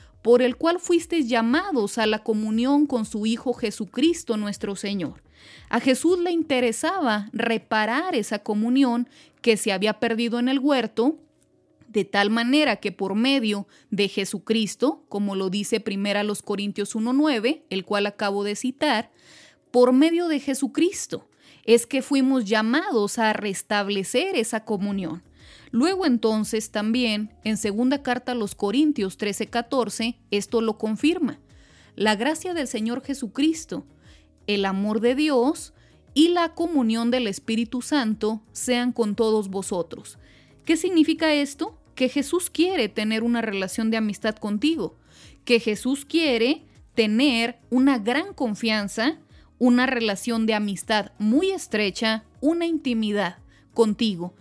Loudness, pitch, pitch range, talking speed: -23 LUFS, 235 Hz, 215-275 Hz, 130 wpm